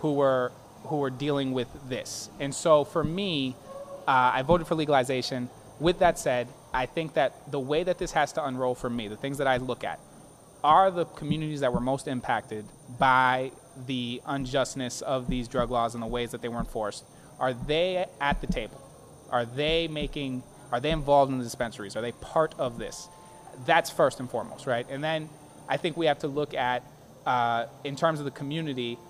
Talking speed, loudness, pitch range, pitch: 200 wpm, -28 LUFS, 125-155 Hz, 135 Hz